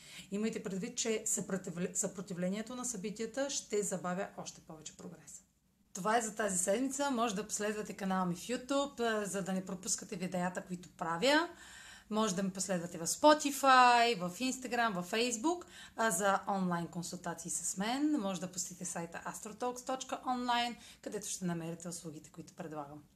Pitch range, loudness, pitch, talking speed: 180-235 Hz, -35 LUFS, 205 Hz, 150 wpm